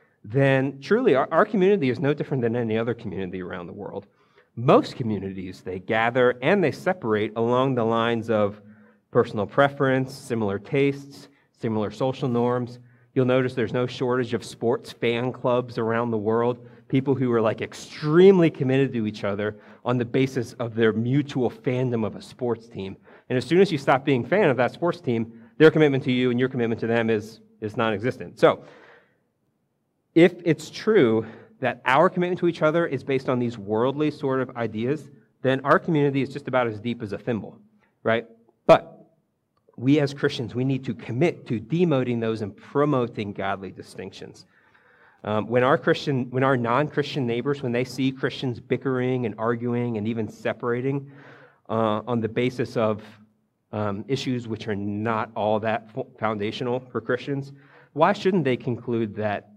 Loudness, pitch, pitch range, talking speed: -24 LUFS, 125 Hz, 110-140 Hz, 175 wpm